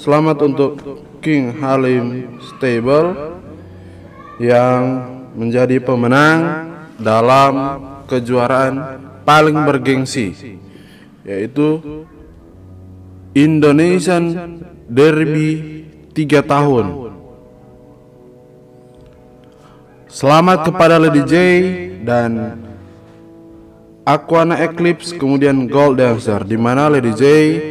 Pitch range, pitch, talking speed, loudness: 120-155 Hz, 140 Hz, 65 wpm, -13 LUFS